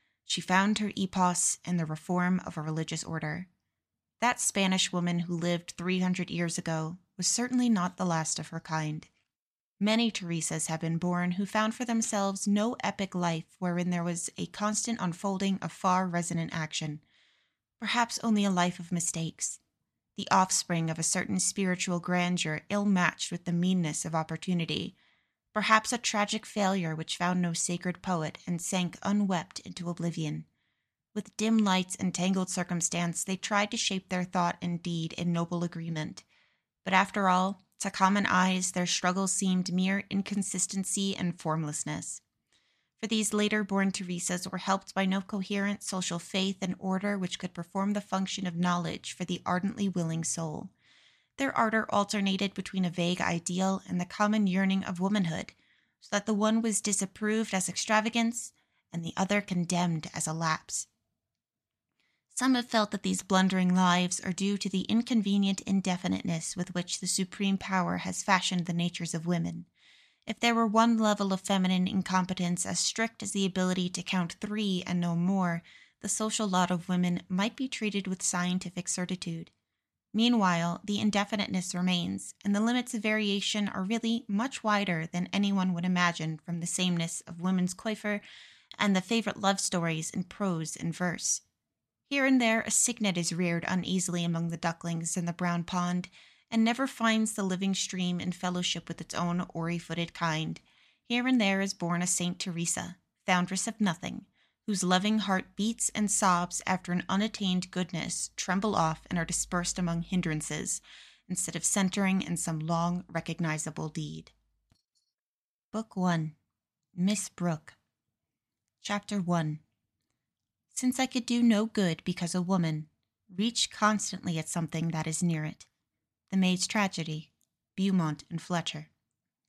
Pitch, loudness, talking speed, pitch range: 185 Hz, -30 LUFS, 160 wpm, 175-200 Hz